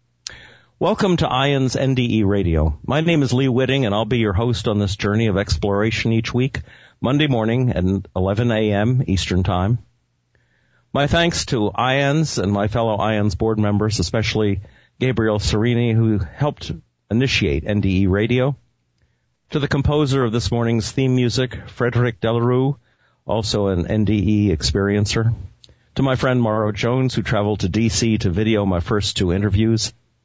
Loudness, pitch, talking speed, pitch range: -19 LUFS, 110 Hz, 150 wpm, 105-125 Hz